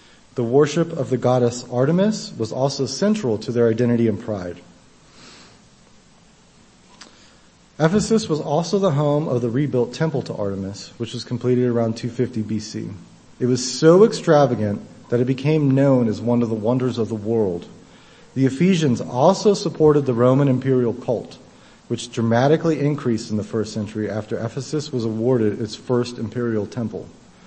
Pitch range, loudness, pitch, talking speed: 115-145 Hz, -20 LUFS, 125 Hz, 155 wpm